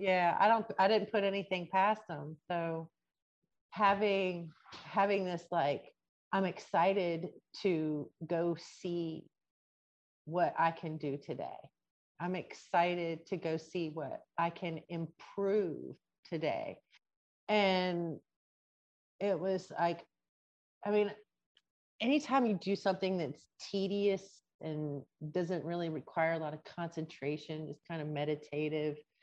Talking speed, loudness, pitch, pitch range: 120 wpm, -35 LUFS, 170 Hz, 155-195 Hz